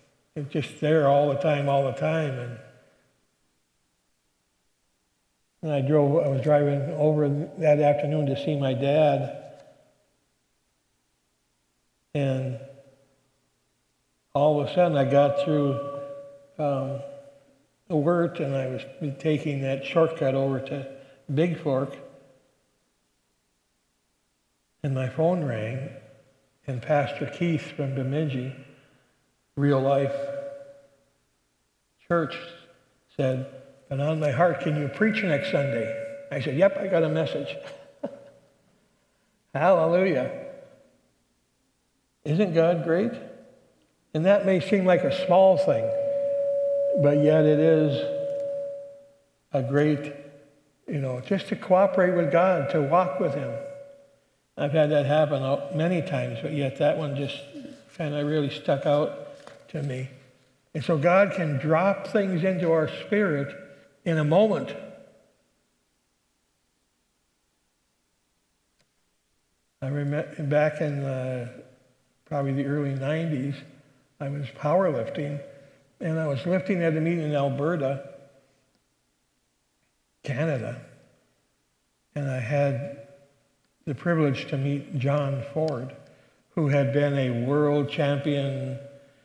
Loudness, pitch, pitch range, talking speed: -25 LUFS, 145 Hz, 135-165 Hz, 115 wpm